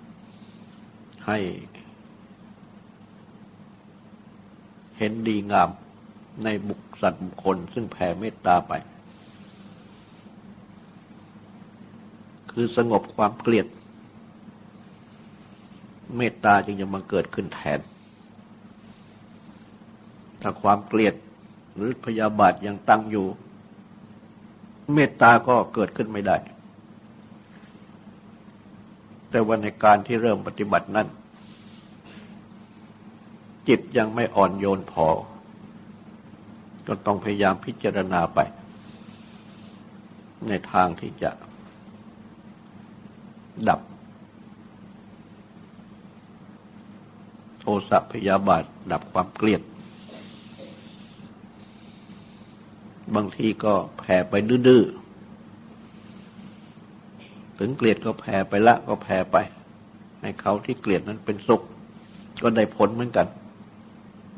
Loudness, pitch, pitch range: -23 LUFS, 110 Hz, 100-120 Hz